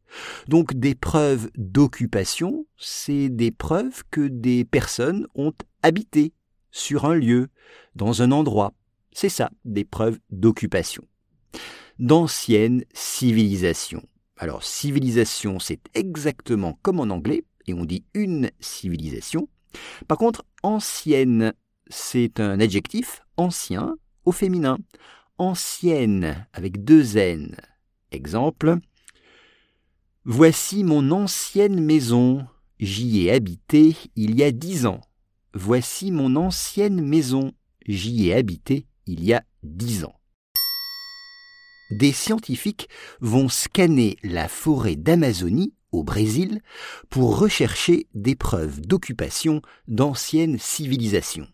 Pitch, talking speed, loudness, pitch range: 130 Hz, 105 wpm, -22 LUFS, 110-165 Hz